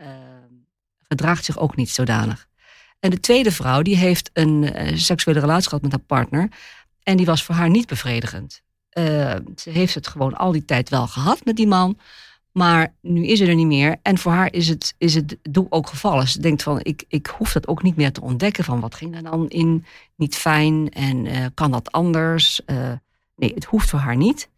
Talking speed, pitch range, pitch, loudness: 220 wpm, 135-175 Hz, 160 Hz, -19 LUFS